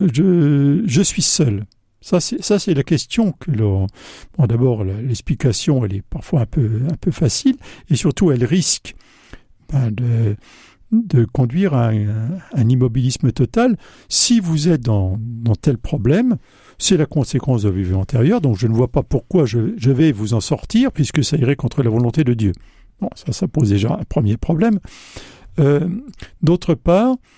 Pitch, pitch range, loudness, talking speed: 140 Hz, 115-170 Hz, -17 LUFS, 175 wpm